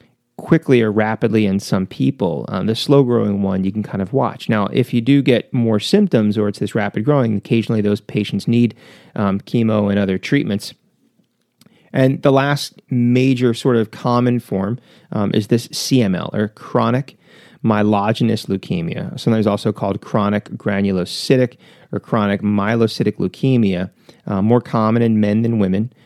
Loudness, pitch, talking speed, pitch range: -17 LUFS, 115 Hz, 160 wpm, 105-125 Hz